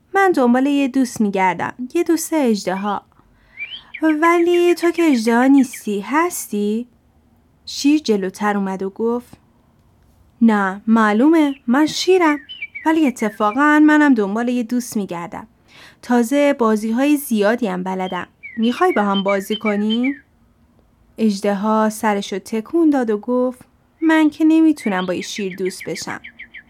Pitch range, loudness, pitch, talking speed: 210-295 Hz, -17 LUFS, 240 Hz, 130 wpm